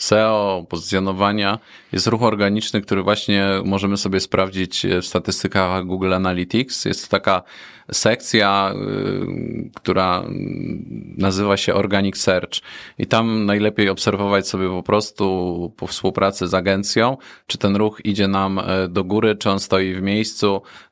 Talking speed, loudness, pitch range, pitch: 130 wpm, -19 LUFS, 95-105 Hz, 100 Hz